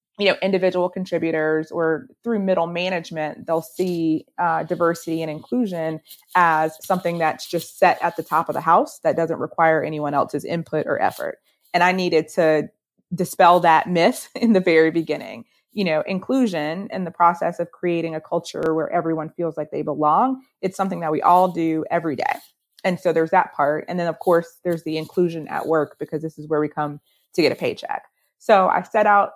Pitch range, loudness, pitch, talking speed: 155-185 Hz, -21 LUFS, 170 Hz, 195 wpm